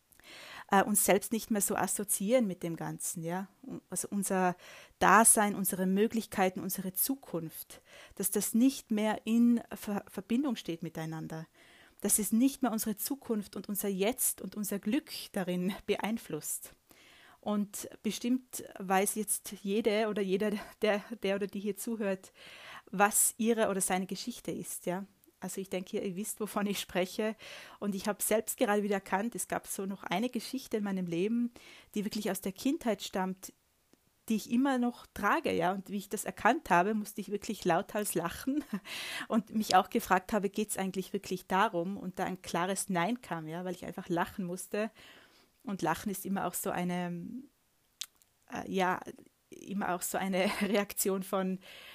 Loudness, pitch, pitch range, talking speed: -32 LUFS, 200 Hz, 185-220 Hz, 165 wpm